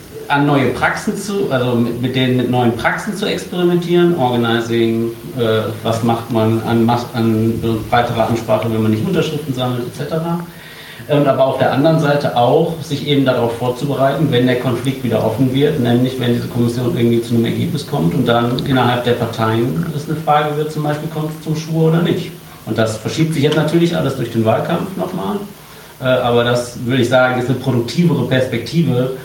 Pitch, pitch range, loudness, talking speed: 130 Hz, 120-155 Hz, -16 LUFS, 190 wpm